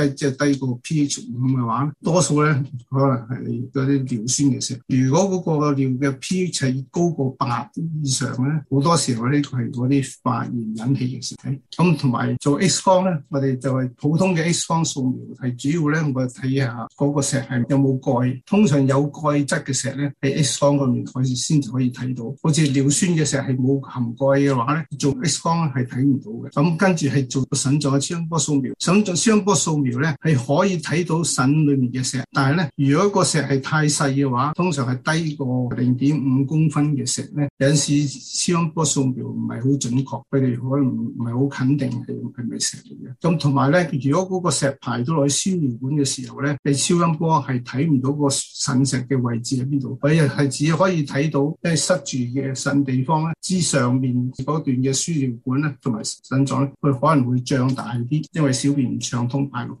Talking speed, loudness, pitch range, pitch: 285 characters per minute, -20 LUFS, 130-150 Hz, 140 Hz